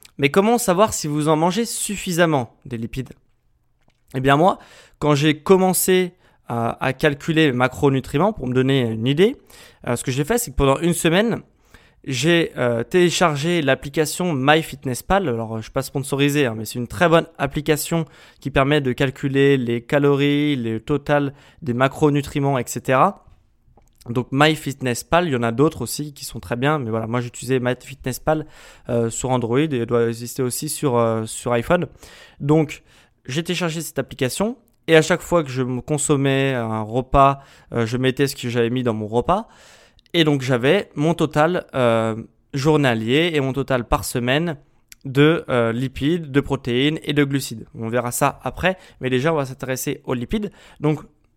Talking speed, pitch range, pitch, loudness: 170 wpm, 125-155 Hz, 140 Hz, -20 LUFS